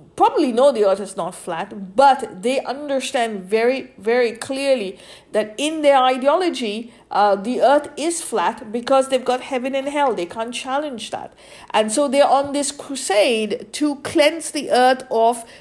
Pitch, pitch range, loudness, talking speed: 260 Hz, 225-285 Hz, -19 LUFS, 165 wpm